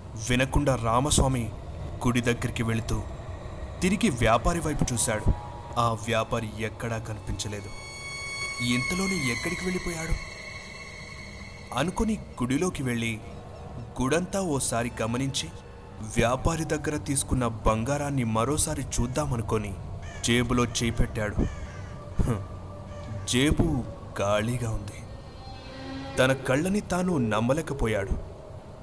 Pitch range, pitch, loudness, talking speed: 105-135 Hz, 115 Hz, -28 LUFS, 75 wpm